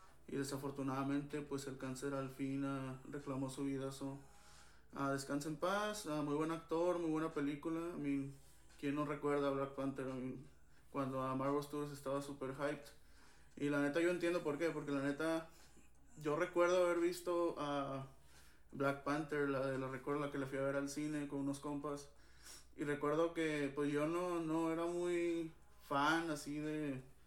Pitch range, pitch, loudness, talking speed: 135-155 Hz, 145 Hz, -41 LUFS, 190 wpm